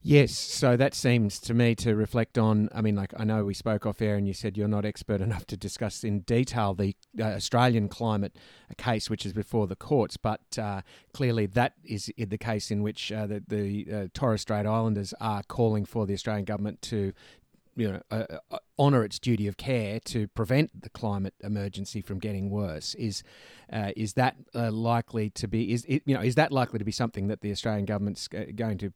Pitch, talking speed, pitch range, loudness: 110 Hz, 215 wpm, 100-115 Hz, -29 LUFS